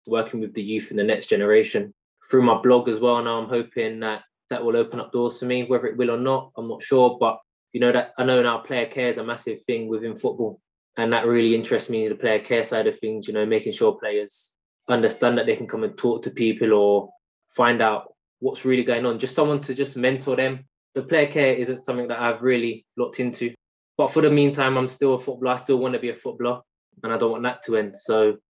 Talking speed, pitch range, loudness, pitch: 250 wpm, 115-130 Hz, -22 LUFS, 125 Hz